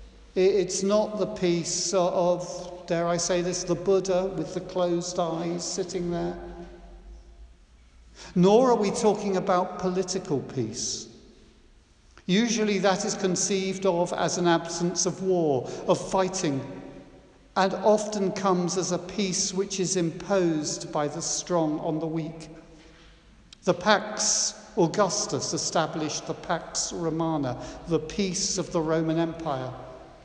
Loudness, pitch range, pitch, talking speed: -26 LUFS, 160-190 Hz, 175 Hz, 130 wpm